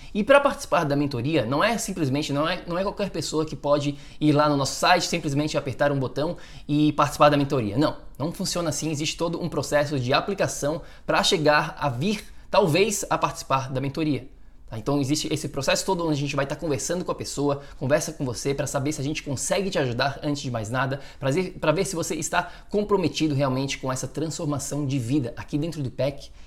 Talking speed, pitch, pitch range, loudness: 215 wpm, 150 Hz, 140-165 Hz, -25 LUFS